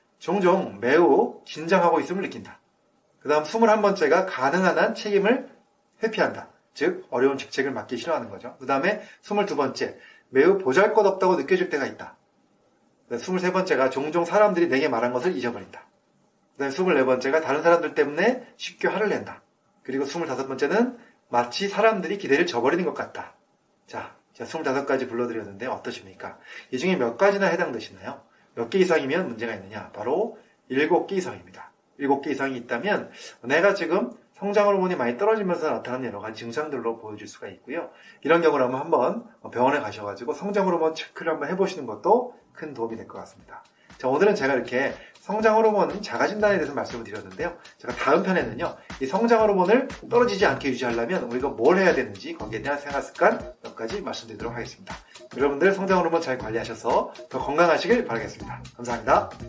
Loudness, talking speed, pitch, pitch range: -24 LUFS, 390 characters per minute, 160 Hz, 130-200 Hz